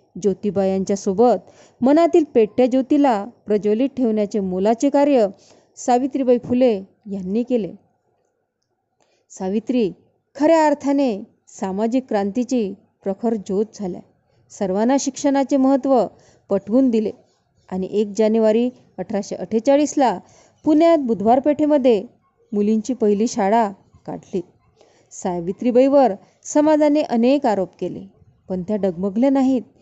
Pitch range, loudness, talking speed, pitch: 200-265 Hz, -19 LUFS, 95 wpm, 230 Hz